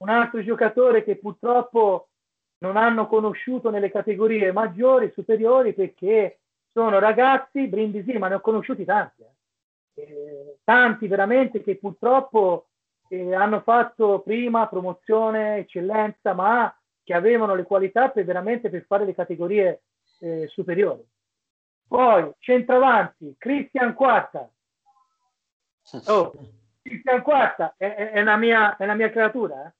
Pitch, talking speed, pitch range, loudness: 220 Hz, 120 wpm, 195-245 Hz, -21 LUFS